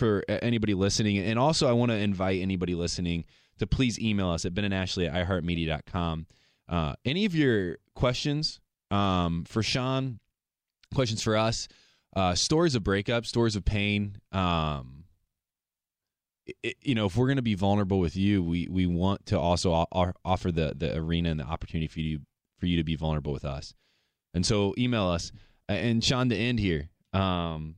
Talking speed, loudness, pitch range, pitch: 175 wpm, -28 LUFS, 85-115 Hz, 95 Hz